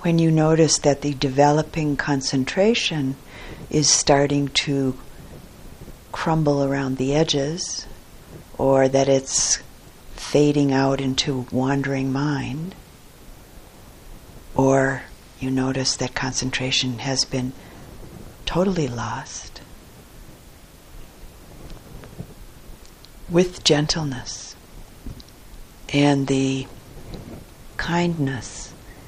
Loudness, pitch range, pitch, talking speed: -21 LUFS, 130-150 Hz, 135 Hz, 75 wpm